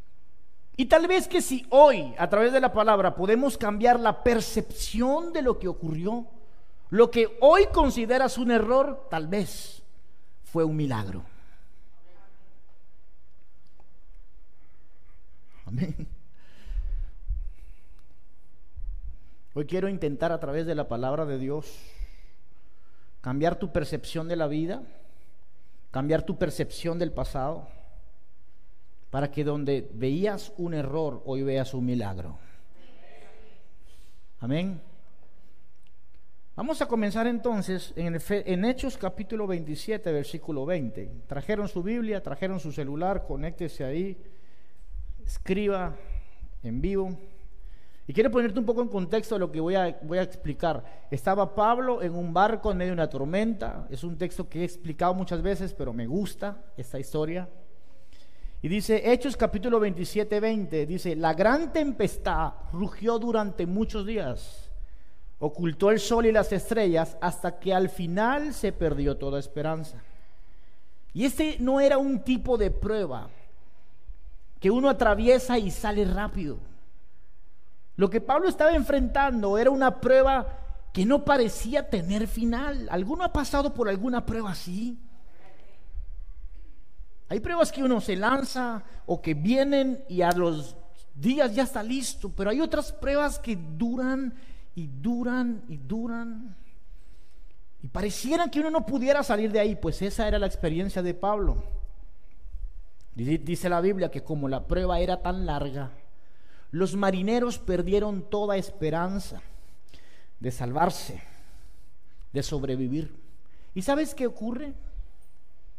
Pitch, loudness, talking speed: 180 Hz, -27 LUFS, 130 wpm